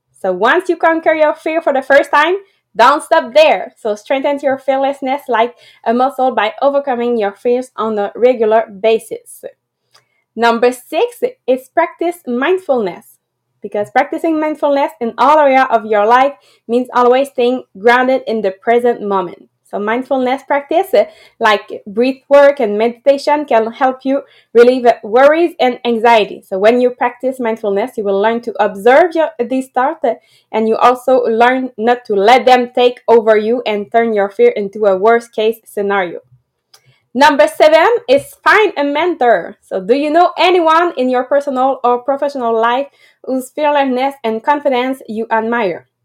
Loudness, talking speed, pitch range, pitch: -13 LUFS, 160 wpm, 225-285 Hz, 250 Hz